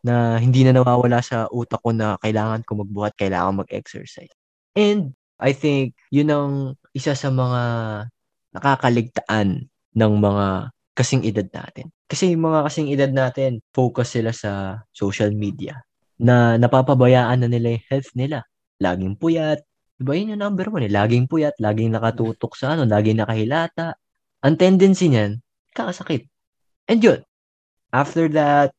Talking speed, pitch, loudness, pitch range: 145 wpm, 125 Hz, -20 LUFS, 110-140 Hz